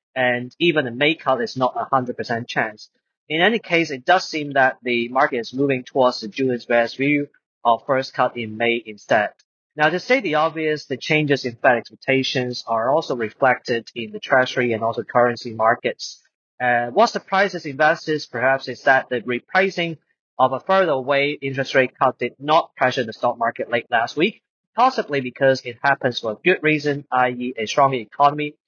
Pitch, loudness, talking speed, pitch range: 130 Hz, -20 LUFS, 190 wpm, 120-150 Hz